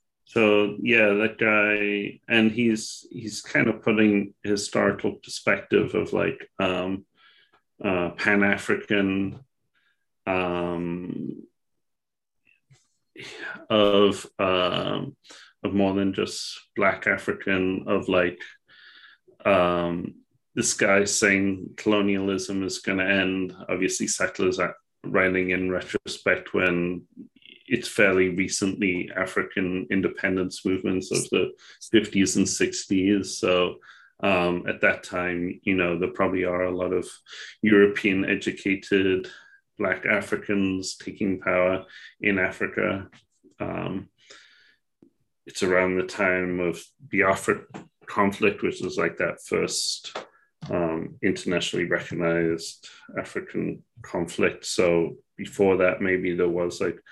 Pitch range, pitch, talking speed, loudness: 90-100 Hz, 95 Hz, 105 wpm, -24 LUFS